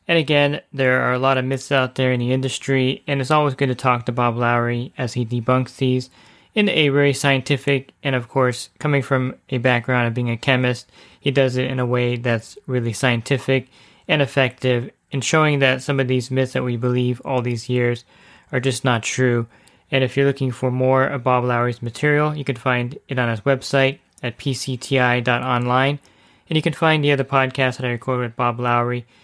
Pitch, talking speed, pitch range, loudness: 130 Hz, 205 wpm, 125-135 Hz, -20 LUFS